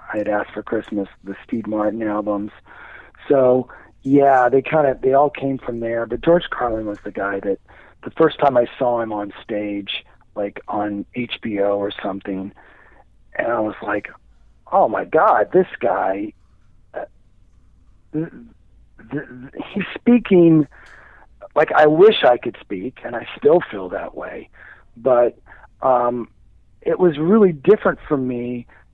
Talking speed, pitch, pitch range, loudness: 150 wpm, 120 Hz, 100-145 Hz, -19 LUFS